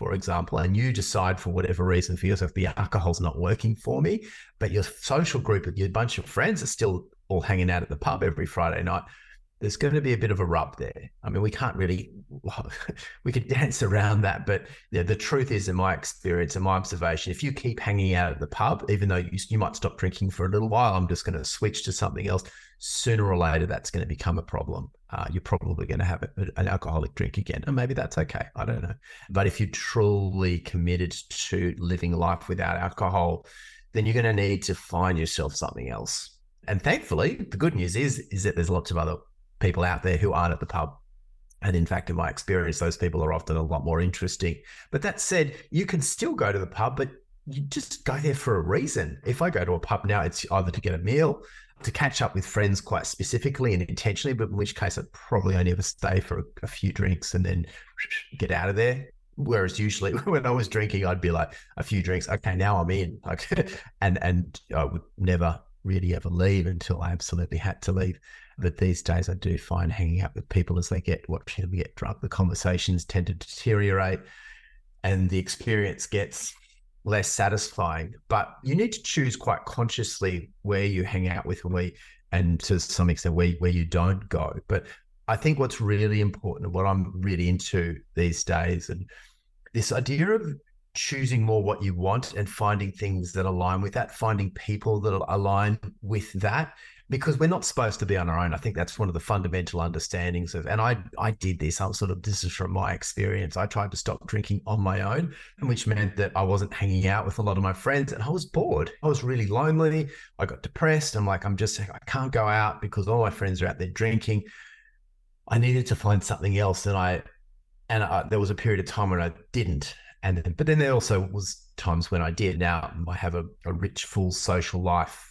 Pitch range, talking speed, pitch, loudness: 90-110 Hz, 220 wpm, 95 Hz, -27 LUFS